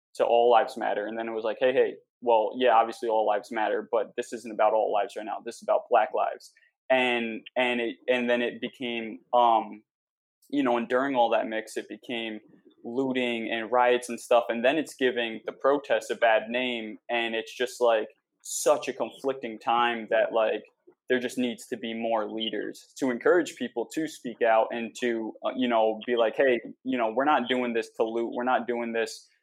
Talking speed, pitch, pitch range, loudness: 210 wpm, 120 Hz, 115-125 Hz, -27 LUFS